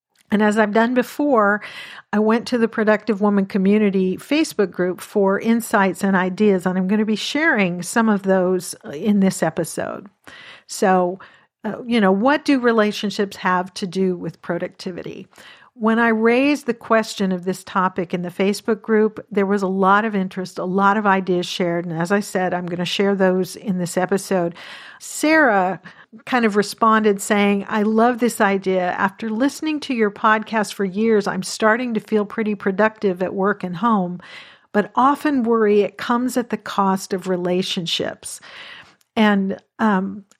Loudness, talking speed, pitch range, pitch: -19 LUFS, 170 wpm, 185-225 Hz, 205 Hz